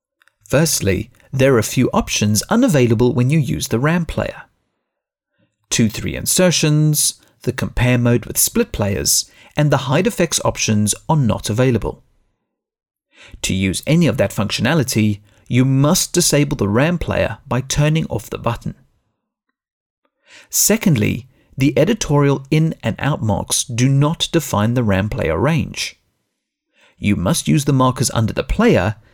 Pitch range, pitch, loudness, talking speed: 110-150 Hz, 125 Hz, -17 LUFS, 140 wpm